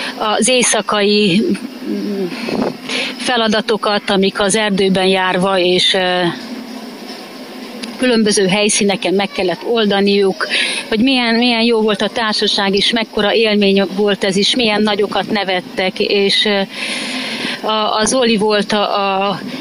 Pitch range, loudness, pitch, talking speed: 200-235 Hz, -14 LUFS, 210 Hz, 110 wpm